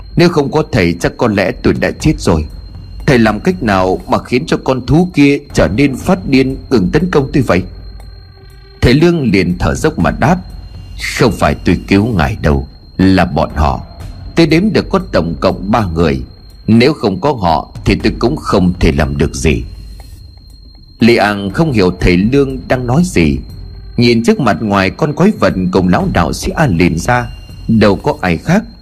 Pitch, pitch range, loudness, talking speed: 95 Hz, 90-130 Hz, -12 LUFS, 195 wpm